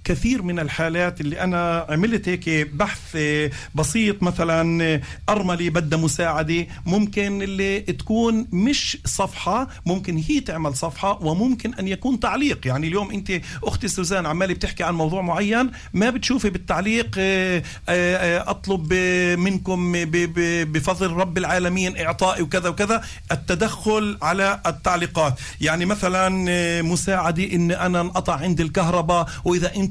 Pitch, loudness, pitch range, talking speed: 180 Hz, -22 LUFS, 170-195 Hz, 120 wpm